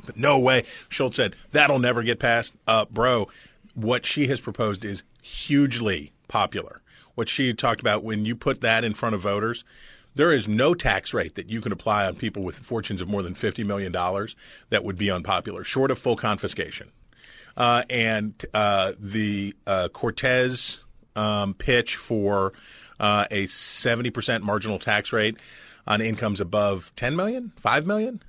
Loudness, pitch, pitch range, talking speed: -24 LUFS, 110 Hz, 105-125 Hz, 165 wpm